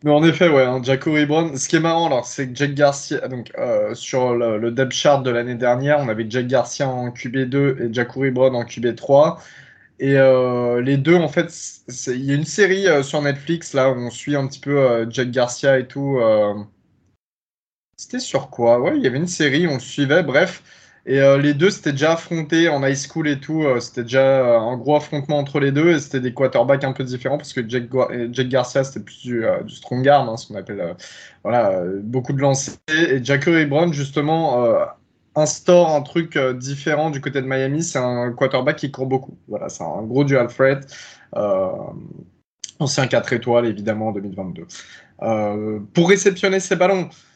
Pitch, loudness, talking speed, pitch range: 135 Hz, -19 LUFS, 210 wpm, 125-155 Hz